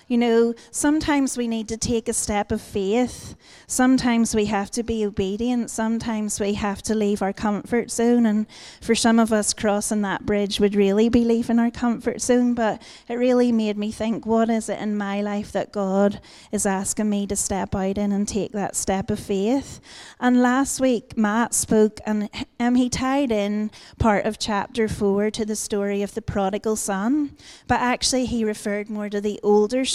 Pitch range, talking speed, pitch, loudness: 205-235 Hz, 190 wpm, 220 Hz, -22 LUFS